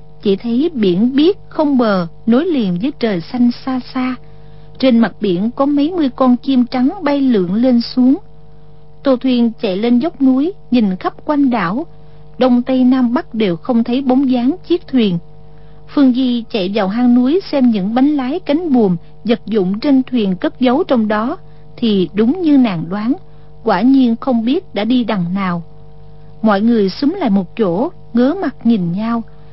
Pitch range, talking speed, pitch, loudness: 195-265 Hz, 185 wpm, 240 Hz, -15 LUFS